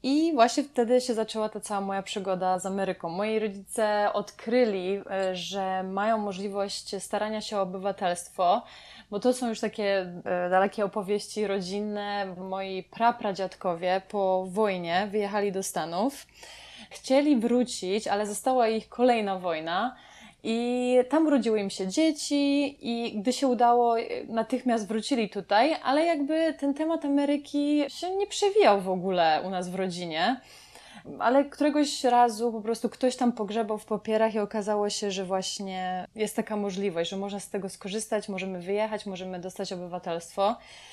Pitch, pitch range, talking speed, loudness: 210 Hz, 195-245 Hz, 145 wpm, -28 LUFS